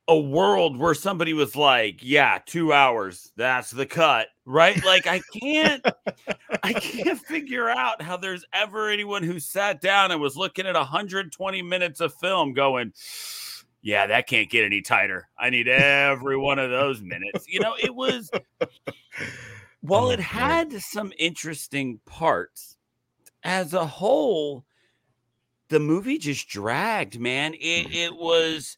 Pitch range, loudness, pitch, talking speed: 140-195 Hz, -23 LUFS, 165 Hz, 145 wpm